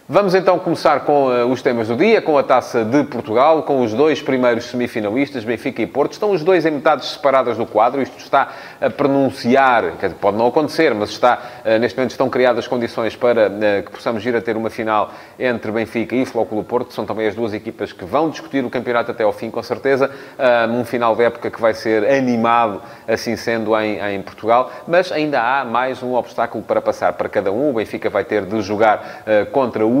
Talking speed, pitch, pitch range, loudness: 220 wpm, 120 Hz, 110-135 Hz, -17 LUFS